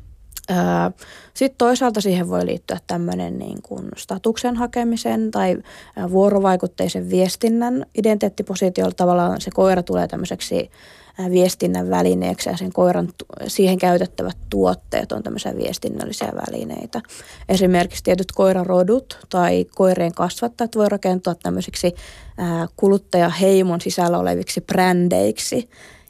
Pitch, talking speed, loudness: 180 Hz, 100 wpm, -20 LUFS